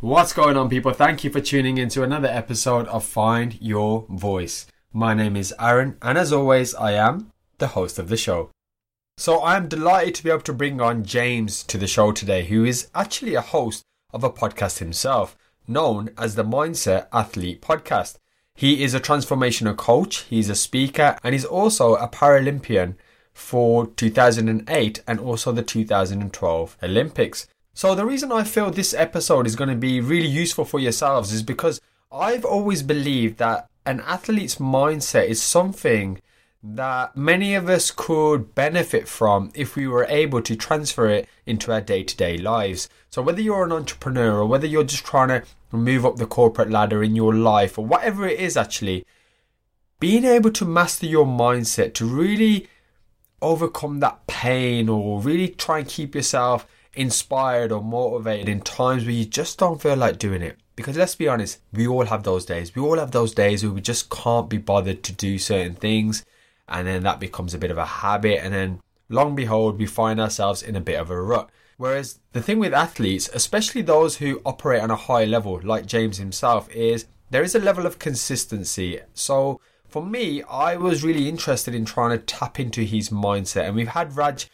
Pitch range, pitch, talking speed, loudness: 110-150 Hz, 120 Hz, 190 wpm, -21 LUFS